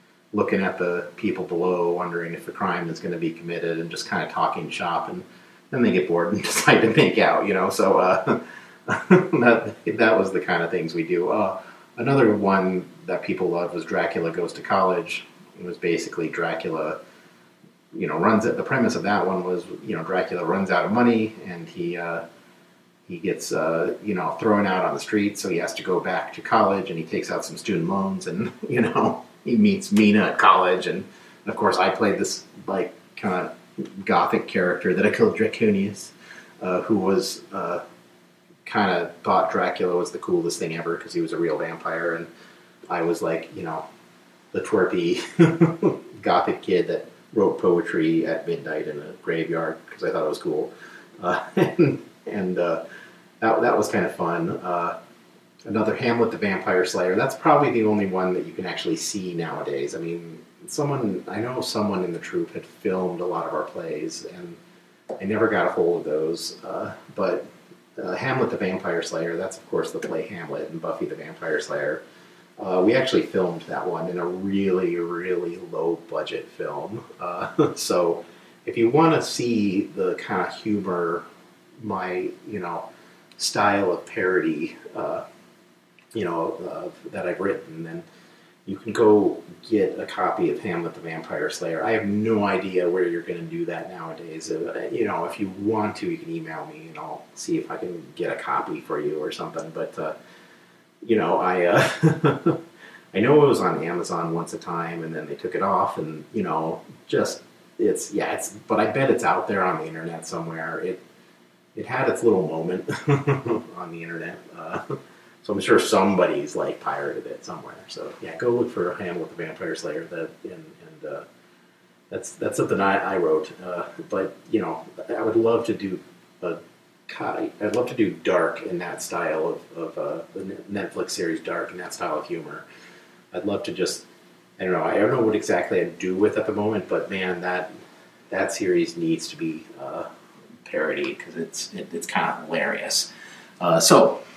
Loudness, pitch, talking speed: -24 LUFS, 115 Hz, 190 wpm